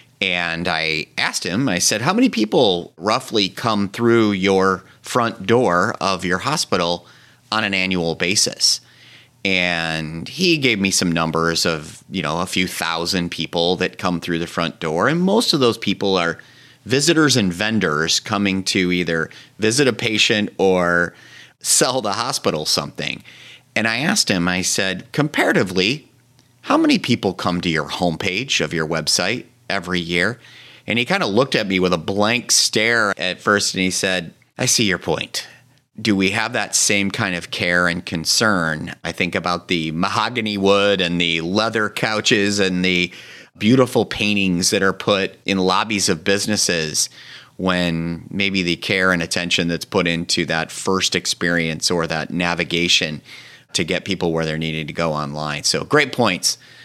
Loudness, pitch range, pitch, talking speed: -18 LUFS, 85-110 Hz, 95 Hz, 165 wpm